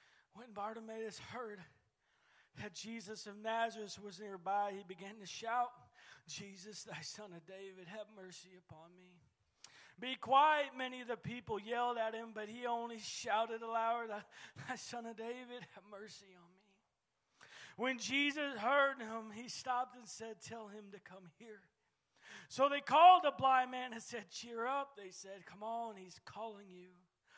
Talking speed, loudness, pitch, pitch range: 160 wpm, -38 LUFS, 220 Hz, 195-240 Hz